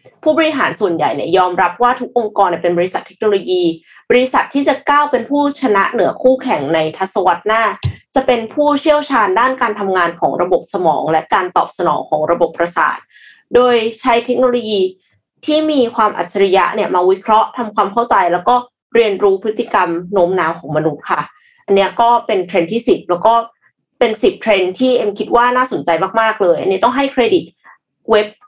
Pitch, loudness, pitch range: 225 Hz, -14 LUFS, 185-250 Hz